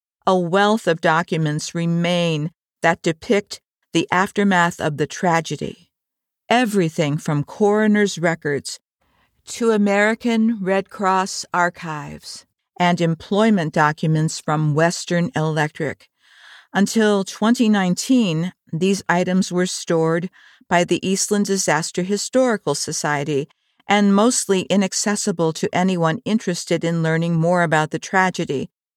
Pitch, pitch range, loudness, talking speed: 180 Hz, 165-205 Hz, -19 LUFS, 105 wpm